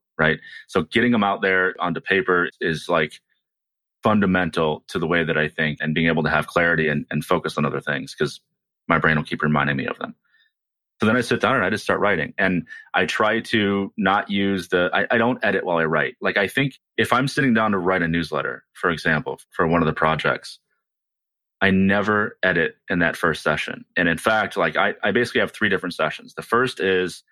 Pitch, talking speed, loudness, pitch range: 95 Hz, 220 wpm, -21 LUFS, 80-105 Hz